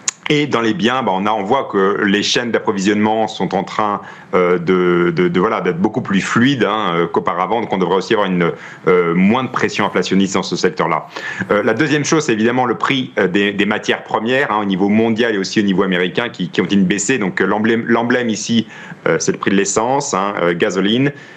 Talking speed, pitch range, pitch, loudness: 220 wpm, 95-115 Hz, 105 Hz, -16 LUFS